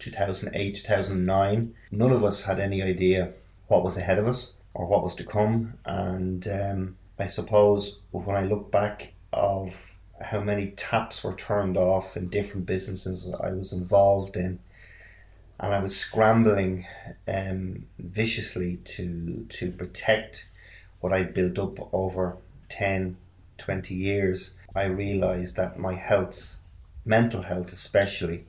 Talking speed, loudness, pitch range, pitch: 135 wpm, -27 LUFS, 90-100 Hz, 95 Hz